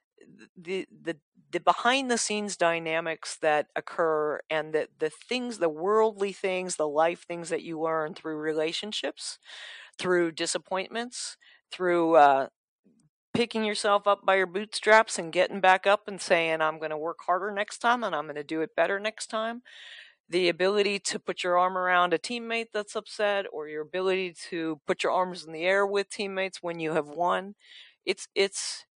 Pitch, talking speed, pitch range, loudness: 185 Hz, 175 wpm, 165-205 Hz, -27 LUFS